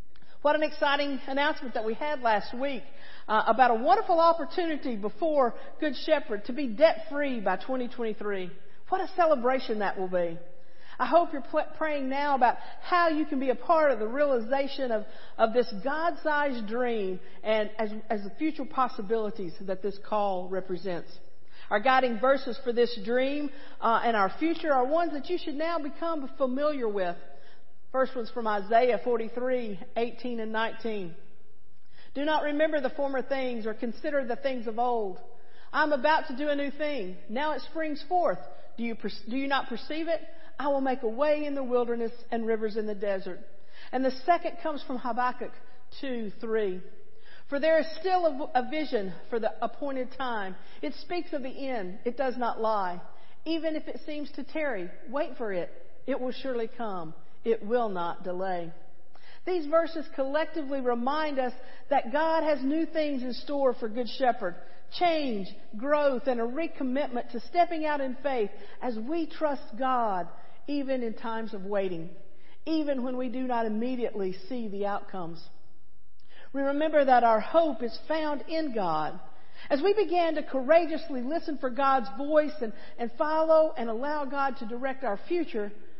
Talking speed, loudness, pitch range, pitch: 175 wpm, -29 LUFS, 220-300 Hz, 255 Hz